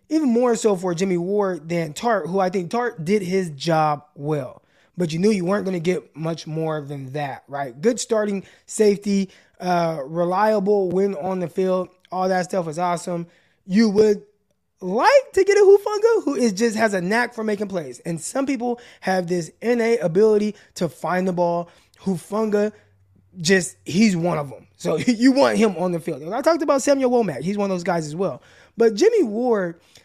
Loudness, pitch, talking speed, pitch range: -21 LUFS, 190 Hz, 200 wpm, 175-225 Hz